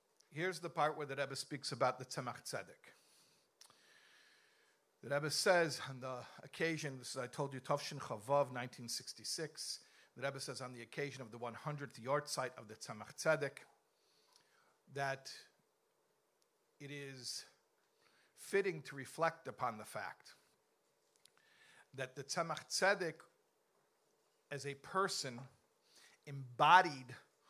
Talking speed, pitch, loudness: 120 wpm, 145 Hz, -40 LUFS